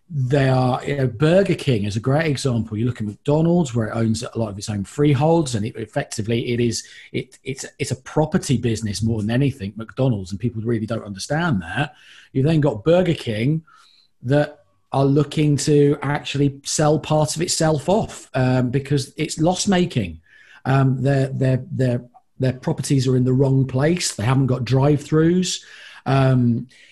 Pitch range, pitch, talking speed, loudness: 120-150 Hz, 135 Hz, 180 wpm, -20 LUFS